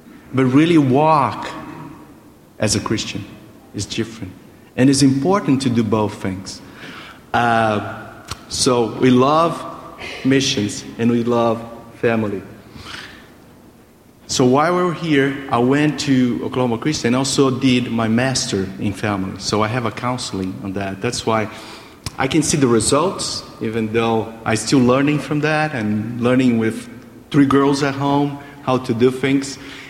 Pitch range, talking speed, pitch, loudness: 110-135 Hz, 145 wpm, 125 Hz, -18 LUFS